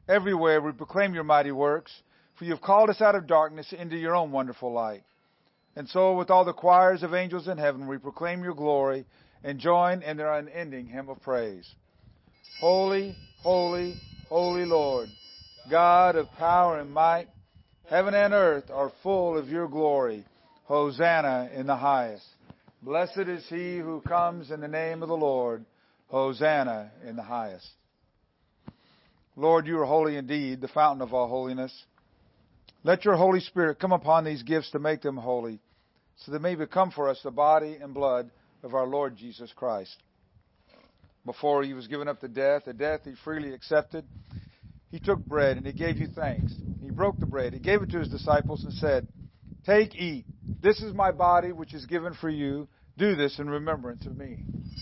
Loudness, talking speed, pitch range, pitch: -26 LUFS, 180 wpm, 130-175 Hz, 150 Hz